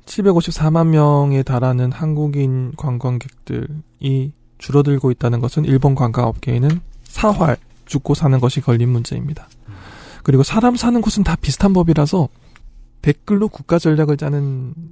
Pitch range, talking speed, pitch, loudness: 125-160 Hz, 295 characters per minute, 140 Hz, -17 LUFS